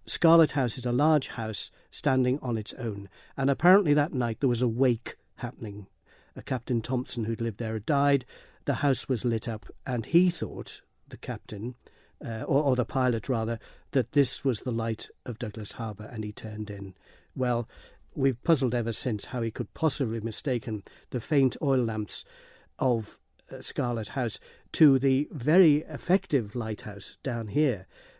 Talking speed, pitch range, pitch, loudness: 170 wpm, 115-135 Hz, 125 Hz, -28 LUFS